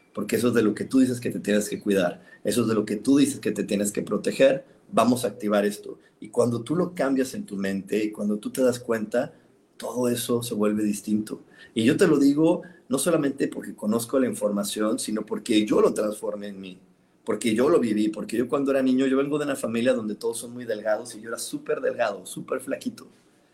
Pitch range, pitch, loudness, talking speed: 105-140 Hz, 120 Hz, -25 LUFS, 235 wpm